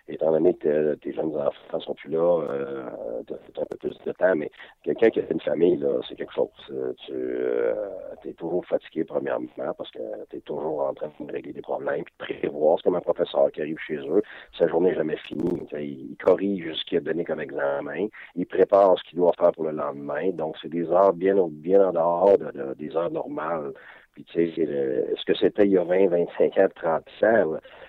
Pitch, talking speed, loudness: 395 Hz, 230 wpm, -25 LUFS